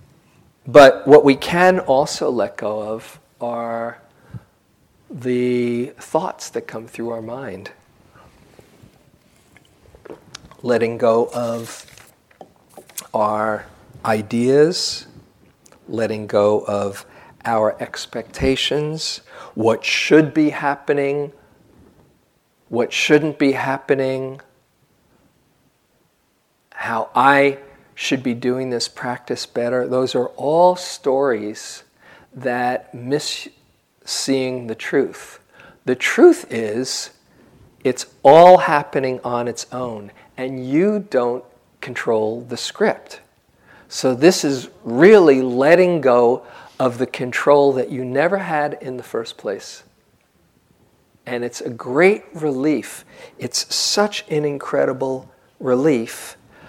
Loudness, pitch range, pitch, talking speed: -18 LUFS, 120-145 Hz, 130 Hz, 100 wpm